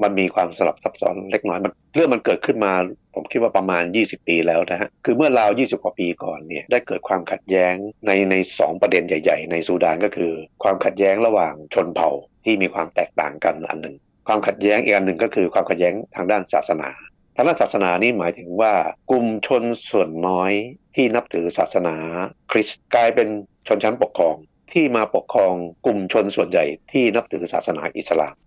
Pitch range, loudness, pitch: 85-105 Hz, -20 LUFS, 95 Hz